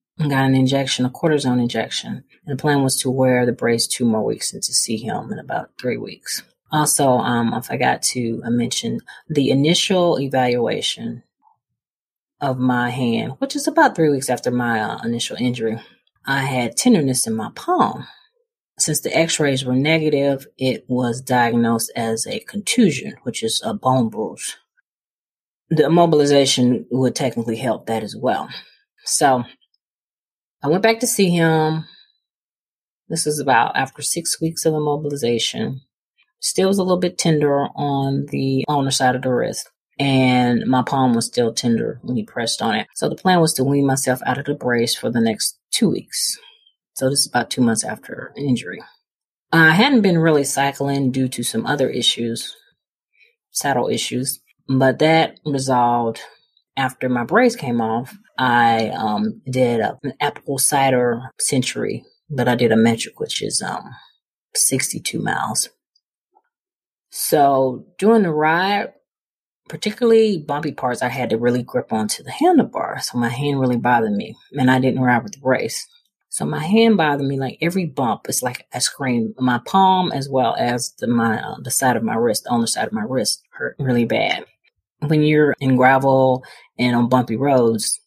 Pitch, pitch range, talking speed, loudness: 135 Hz, 120-155 Hz, 170 wpm, -19 LUFS